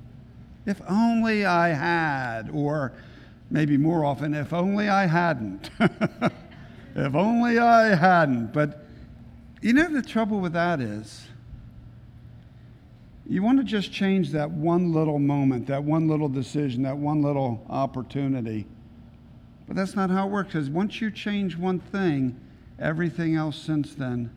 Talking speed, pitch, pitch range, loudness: 140 wpm, 150 Hz, 130-190 Hz, -24 LUFS